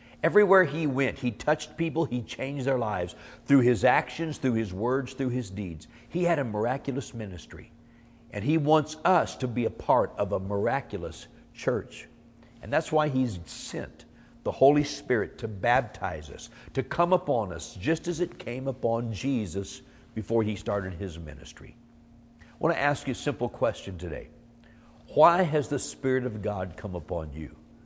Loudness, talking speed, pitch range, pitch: -28 LUFS, 170 wpm, 105-140 Hz, 120 Hz